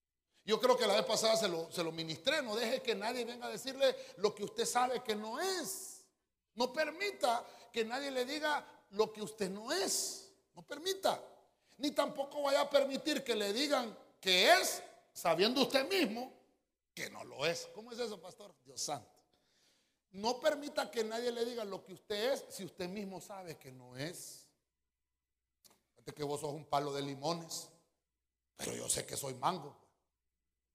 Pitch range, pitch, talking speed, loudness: 165-265 Hz, 220 Hz, 180 wpm, -36 LUFS